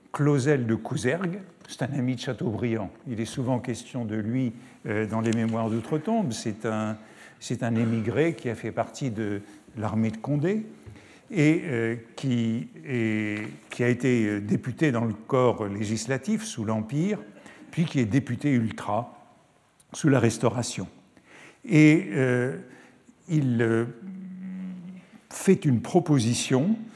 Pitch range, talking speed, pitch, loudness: 115-155 Hz, 125 wpm, 125 Hz, -26 LUFS